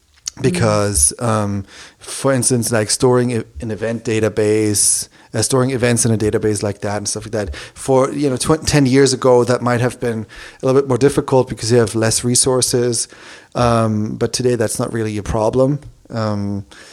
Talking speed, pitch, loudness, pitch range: 185 wpm, 115 Hz, -16 LUFS, 105-125 Hz